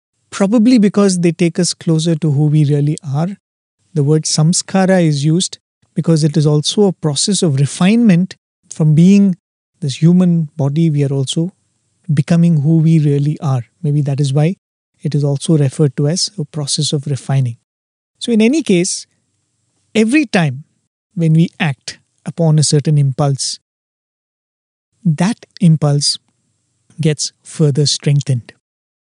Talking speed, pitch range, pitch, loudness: 145 wpm, 145-175 Hz, 155 Hz, -14 LUFS